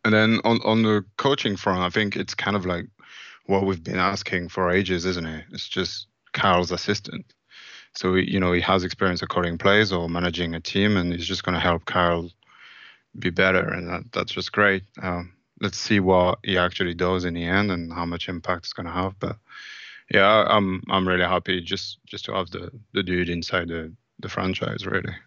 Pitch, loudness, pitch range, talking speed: 95 Hz, -23 LUFS, 90-100 Hz, 210 wpm